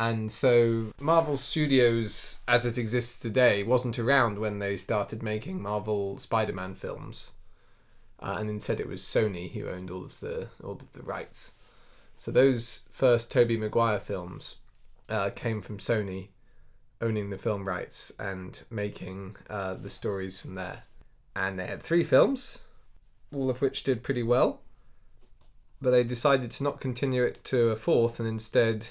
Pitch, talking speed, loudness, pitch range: 115 Hz, 160 wpm, -28 LUFS, 100-125 Hz